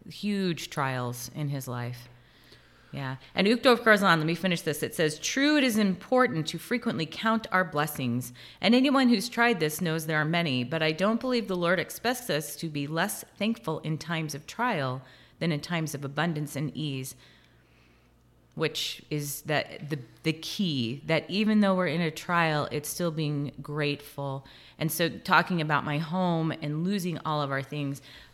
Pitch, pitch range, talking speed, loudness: 155 Hz, 145-185 Hz, 180 wpm, -28 LUFS